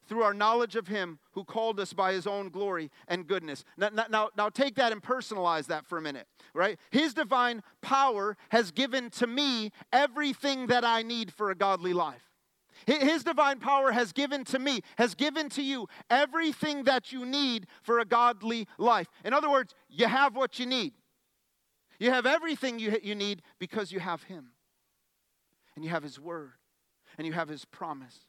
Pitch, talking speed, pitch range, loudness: 230 Hz, 185 wpm, 190-265 Hz, -29 LUFS